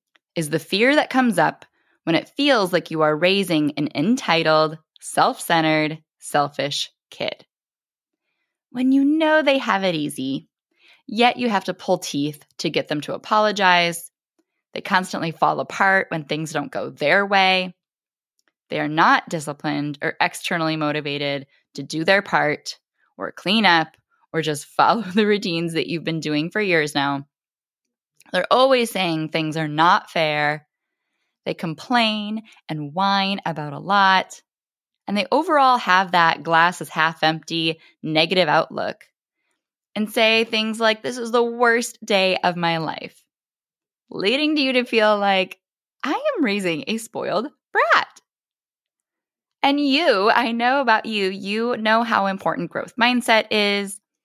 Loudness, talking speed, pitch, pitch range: -20 LUFS, 150 wpm, 190 Hz, 160-230 Hz